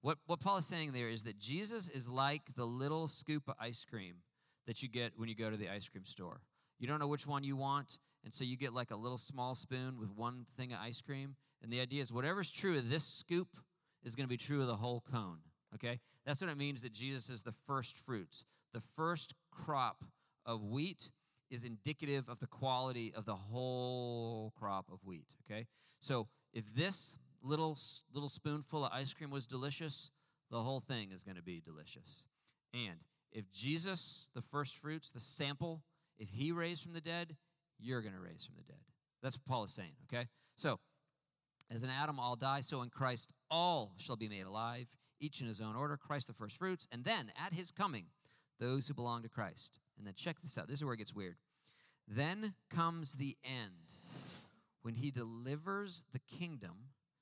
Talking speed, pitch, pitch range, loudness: 205 wpm, 135 Hz, 120-150 Hz, -42 LUFS